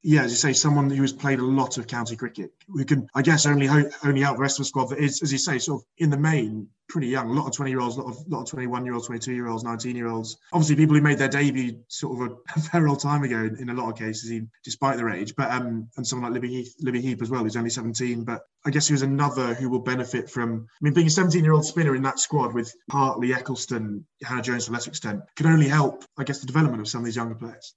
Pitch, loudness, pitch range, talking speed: 130 Hz, -24 LUFS, 120-145 Hz, 270 wpm